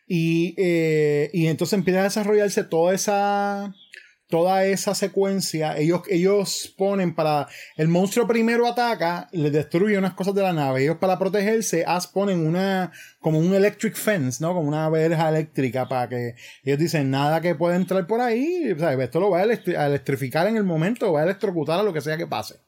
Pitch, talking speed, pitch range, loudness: 175 Hz, 185 wpm, 155-200 Hz, -22 LUFS